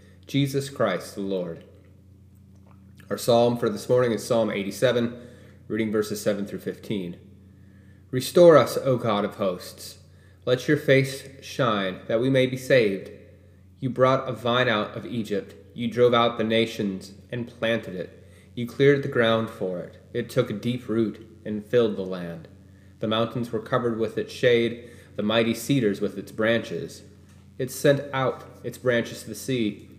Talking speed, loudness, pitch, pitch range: 165 wpm, -24 LUFS, 110 Hz, 100-120 Hz